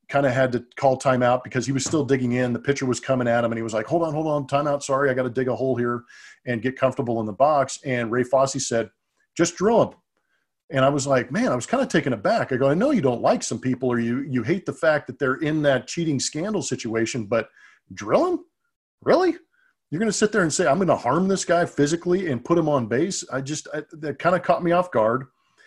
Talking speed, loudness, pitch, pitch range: 270 wpm, -23 LUFS, 140 Hz, 125-170 Hz